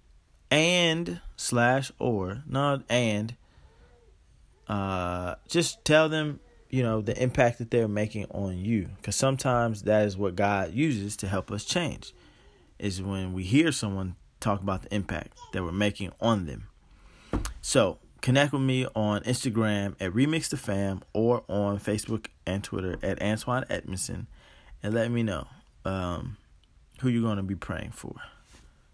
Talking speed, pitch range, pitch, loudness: 150 wpm, 95-125 Hz, 105 Hz, -28 LUFS